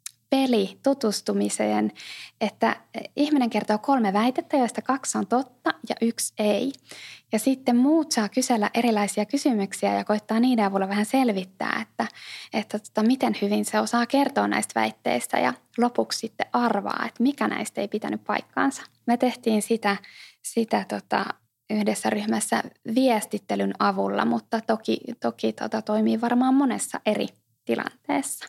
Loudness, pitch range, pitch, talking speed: -25 LUFS, 195-250 Hz, 220 Hz, 135 wpm